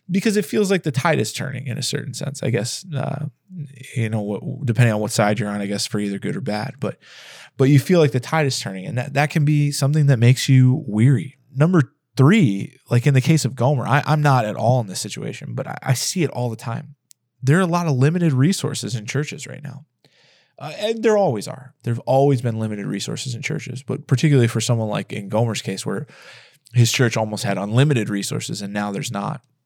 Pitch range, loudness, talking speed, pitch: 120-150 Hz, -20 LUFS, 235 wpm, 135 Hz